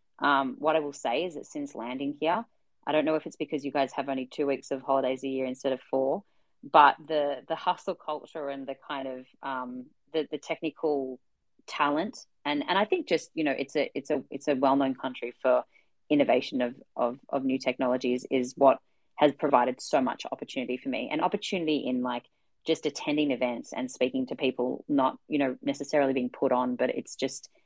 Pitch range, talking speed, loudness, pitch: 130-155 Hz, 210 wpm, -29 LUFS, 140 Hz